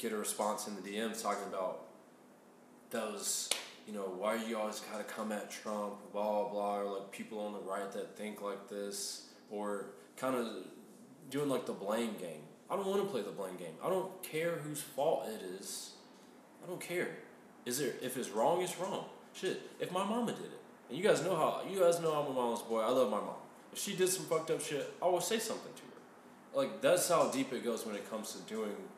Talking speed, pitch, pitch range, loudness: 225 wpm, 115 Hz, 105-170 Hz, -37 LUFS